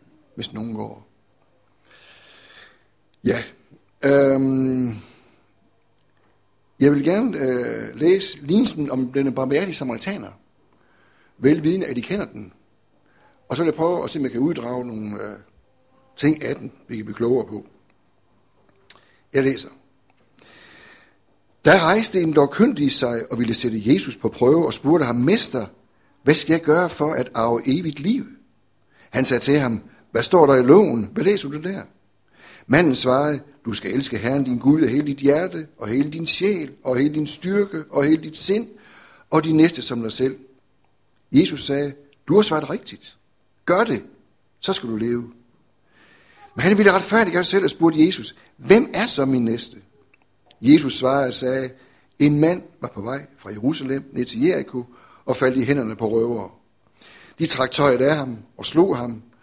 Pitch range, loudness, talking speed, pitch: 120-155 Hz, -19 LUFS, 170 wpm, 135 Hz